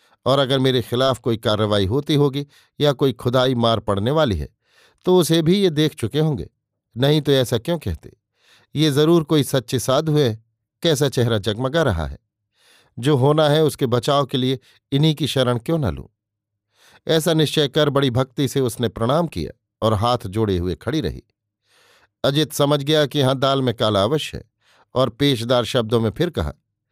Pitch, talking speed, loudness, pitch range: 130 Hz, 180 wpm, -19 LUFS, 115-150 Hz